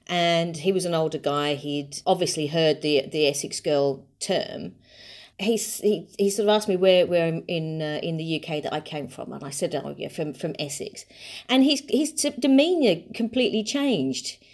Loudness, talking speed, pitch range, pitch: -24 LUFS, 200 wpm, 150-210 Hz, 170 Hz